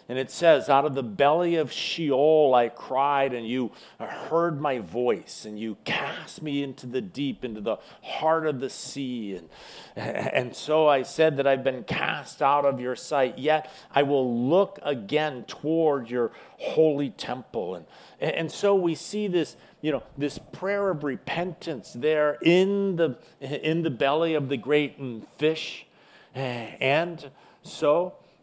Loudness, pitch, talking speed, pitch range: -26 LUFS, 145 Hz, 160 wpm, 130-160 Hz